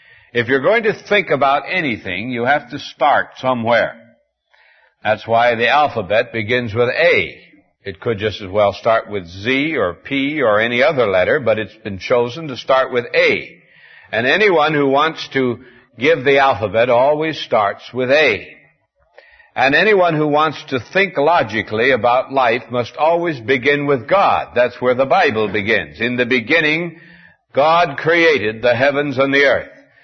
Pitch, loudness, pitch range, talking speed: 130 Hz, -16 LUFS, 120-150 Hz, 165 wpm